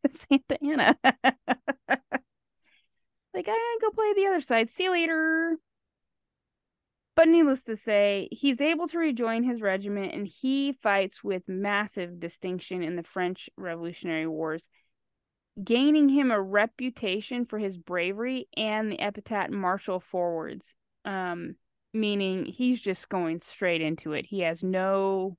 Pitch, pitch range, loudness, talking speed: 210 Hz, 185-270 Hz, -27 LUFS, 135 wpm